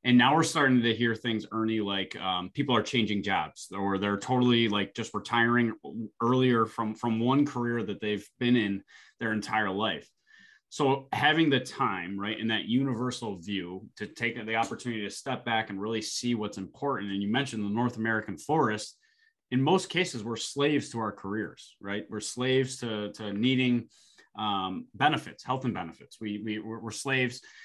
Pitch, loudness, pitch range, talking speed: 115 Hz, -29 LUFS, 105-125 Hz, 180 wpm